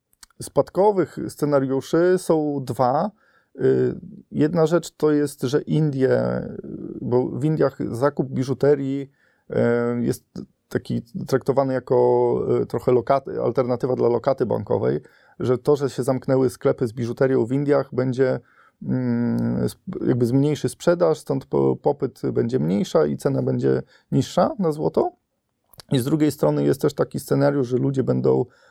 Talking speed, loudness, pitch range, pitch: 125 wpm, -22 LUFS, 120-150 Hz, 135 Hz